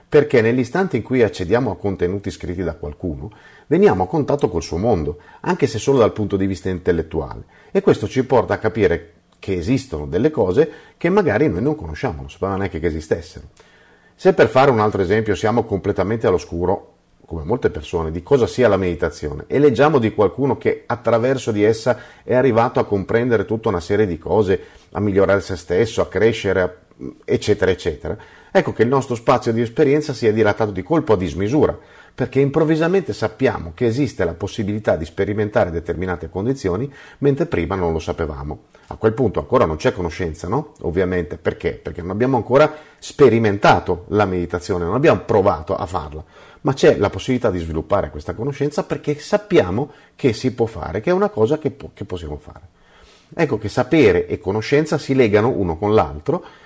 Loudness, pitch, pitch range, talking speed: -19 LUFS, 110 Hz, 95-140 Hz, 180 wpm